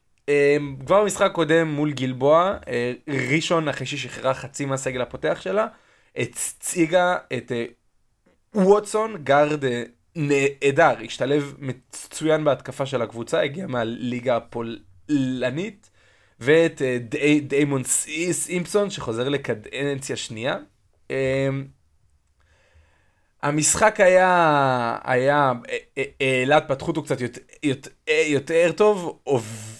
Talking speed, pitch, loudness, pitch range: 95 wpm, 140 Hz, -22 LUFS, 125-160 Hz